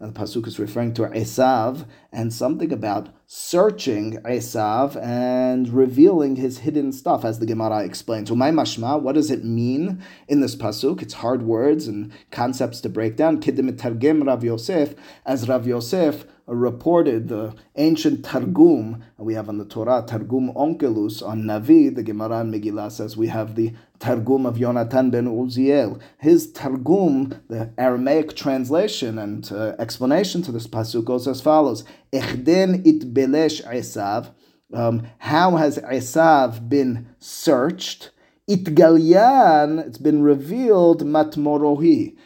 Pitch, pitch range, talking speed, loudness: 125 Hz, 115-150 Hz, 140 wpm, -20 LUFS